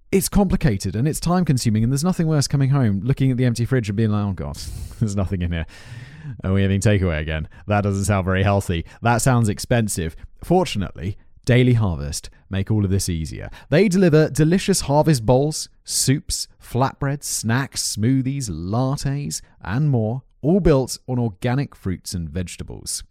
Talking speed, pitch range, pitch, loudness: 170 wpm, 95-135 Hz, 115 Hz, -21 LUFS